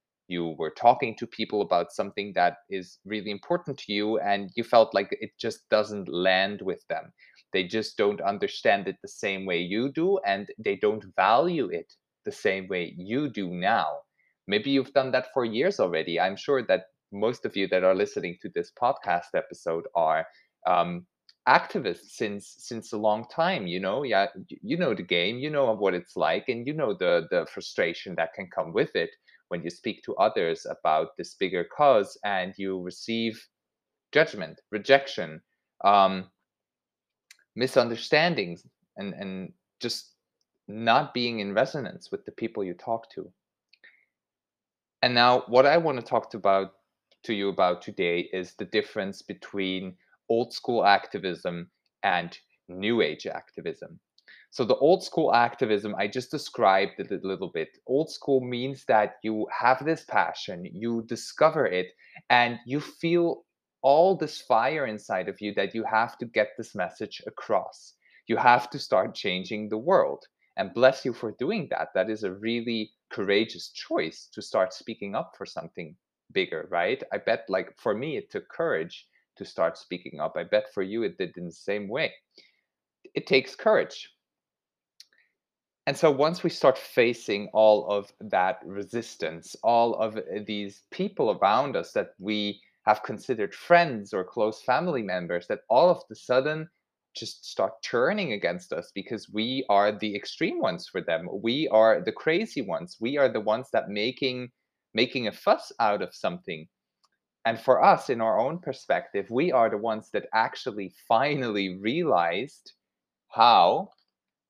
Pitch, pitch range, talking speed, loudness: 110 Hz, 100-130 Hz, 165 wpm, -26 LUFS